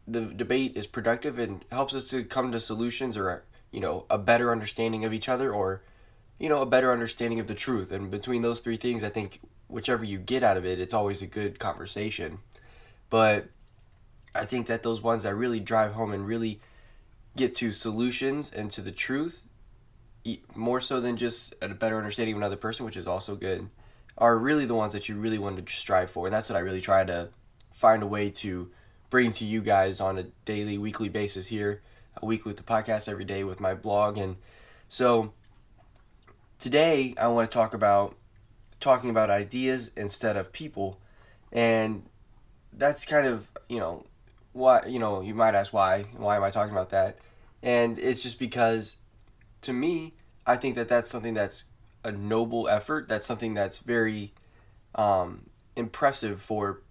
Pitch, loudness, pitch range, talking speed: 110 Hz, -28 LUFS, 100-120 Hz, 185 wpm